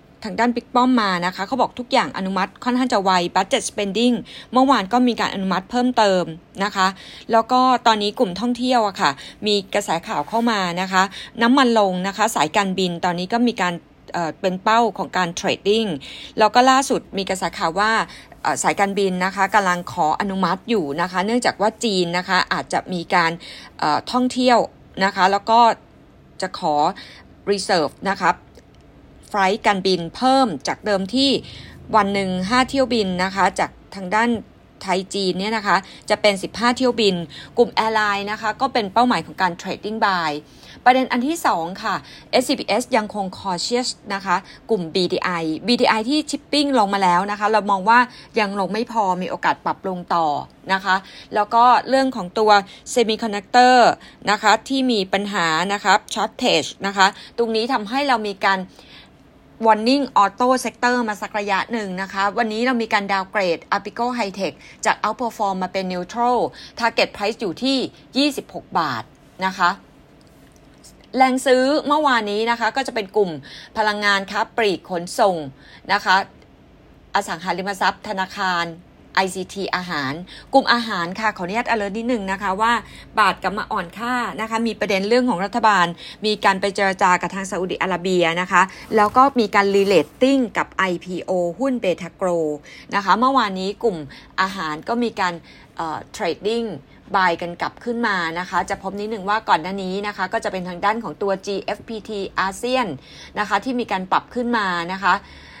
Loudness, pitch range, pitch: -20 LUFS, 185-235 Hz, 205 Hz